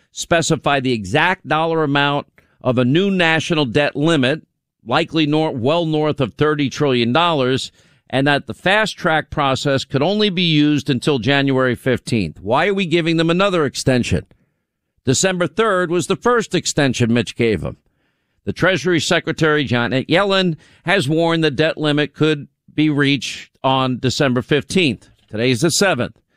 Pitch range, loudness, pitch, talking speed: 130-165 Hz, -17 LUFS, 150 Hz, 155 wpm